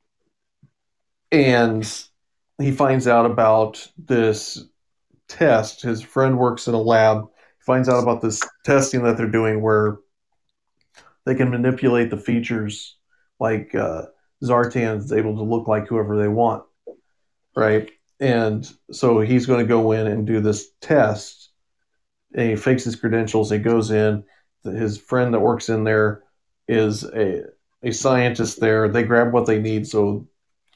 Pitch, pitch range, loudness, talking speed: 115 Hz, 110-125 Hz, -20 LUFS, 150 wpm